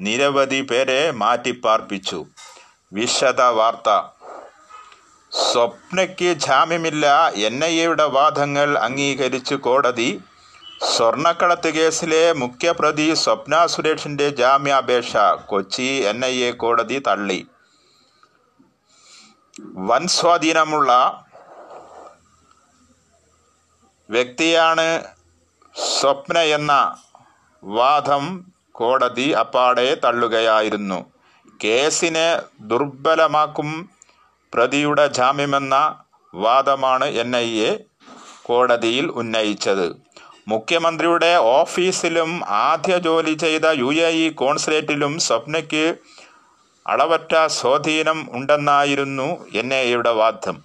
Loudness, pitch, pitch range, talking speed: -18 LUFS, 145 Hz, 125-165 Hz, 70 wpm